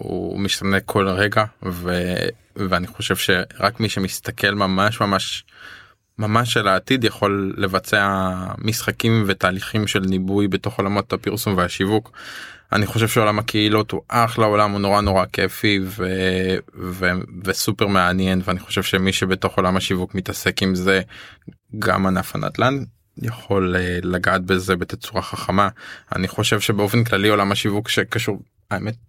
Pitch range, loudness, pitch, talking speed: 95-105 Hz, -20 LUFS, 100 Hz, 135 wpm